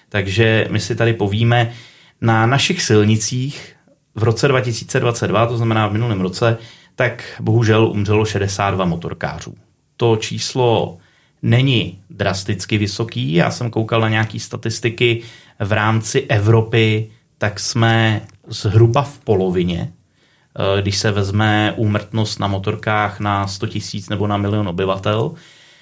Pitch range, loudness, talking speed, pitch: 105-115 Hz, -17 LUFS, 125 wpm, 110 Hz